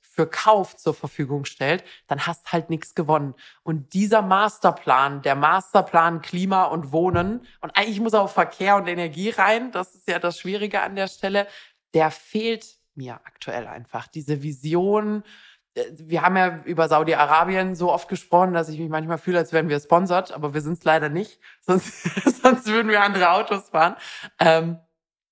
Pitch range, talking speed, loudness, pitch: 160-200 Hz, 175 wpm, -21 LUFS, 175 Hz